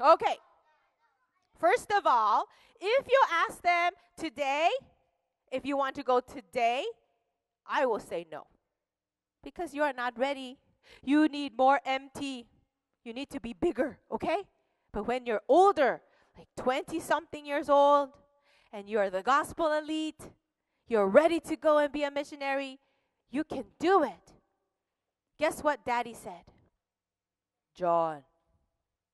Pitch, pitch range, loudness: 275 Hz, 235-315 Hz, -29 LUFS